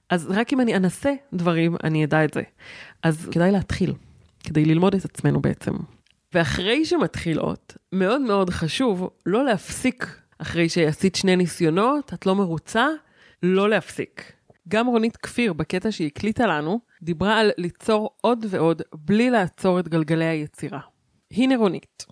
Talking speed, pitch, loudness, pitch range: 145 wpm, 185 Hz, -22 LUFS, 165-220 Hz